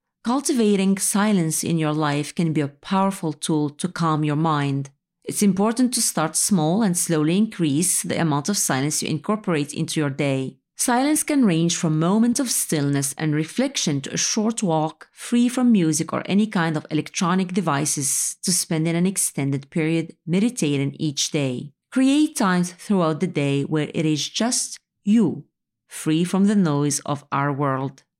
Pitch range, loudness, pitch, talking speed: 150-205 Hz, -21 LUFS, 165 Hz, 170 wpm